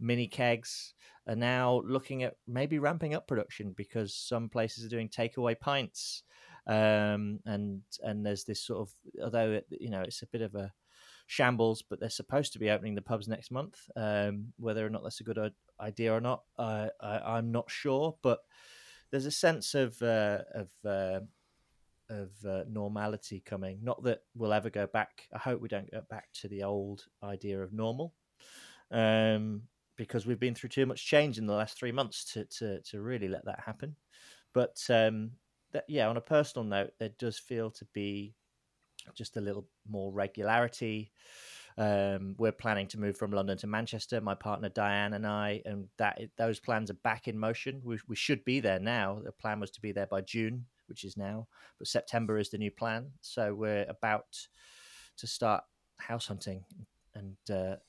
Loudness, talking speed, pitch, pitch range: -34 LUFS, 190 wpm, 110 Hz, 105-120 Hz